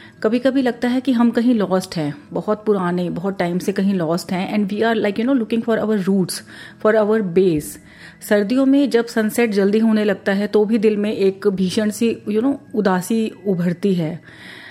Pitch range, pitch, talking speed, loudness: 190-230 Hz, 210 Hz, 210 wpm, -18 LUFS